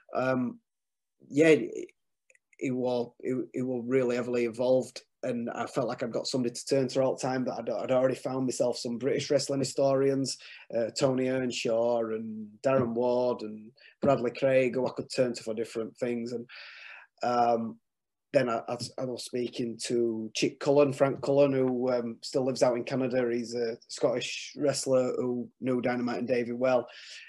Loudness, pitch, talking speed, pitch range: -29 LUFS, 125 Hz, 170 wpm, 120-130 Hz